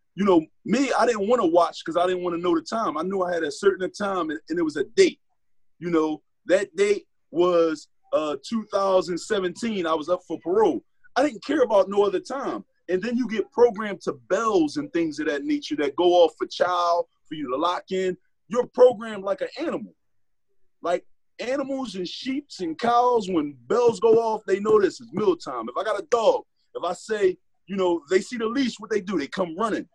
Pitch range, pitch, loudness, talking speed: 180-305 Hz, 225 Hz, -24 LUFS, 220 wpm